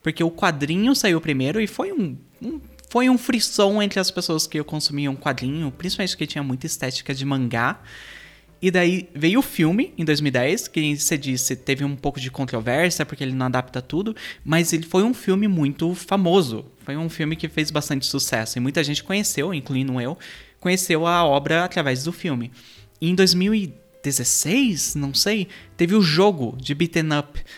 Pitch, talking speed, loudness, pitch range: 160 Hz, 185 wpm, -21 LUFS, 140-185 Hz